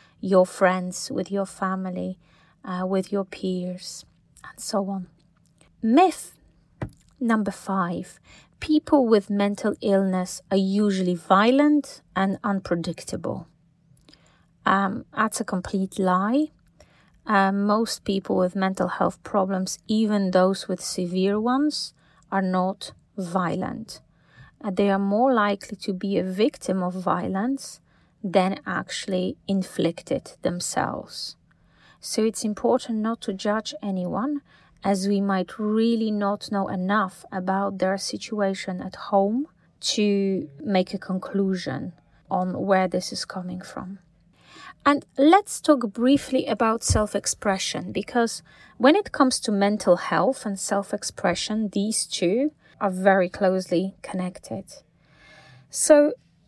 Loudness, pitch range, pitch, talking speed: -24 LUFS, 185-220 Hz, 195 Hz, 115 wpm